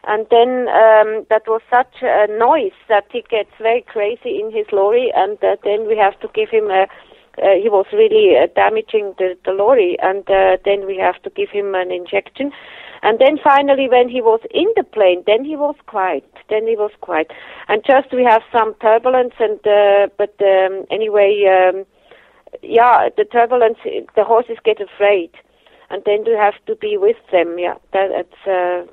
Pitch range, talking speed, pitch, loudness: 200-285 Hz, 190 wpm, 220 Hz, -15 LUFS